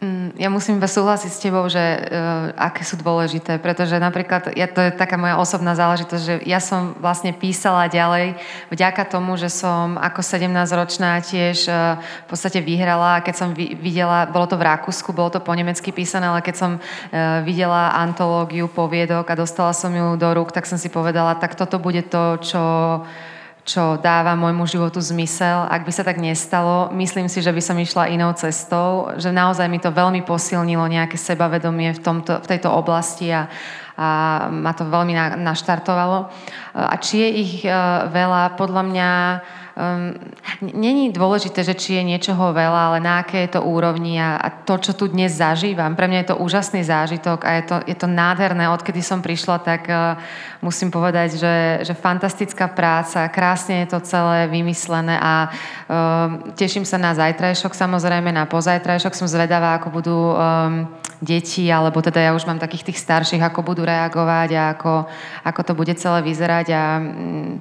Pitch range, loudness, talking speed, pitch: 165-180 Hz, -19 LUFS, 170 wpm, 175 Hz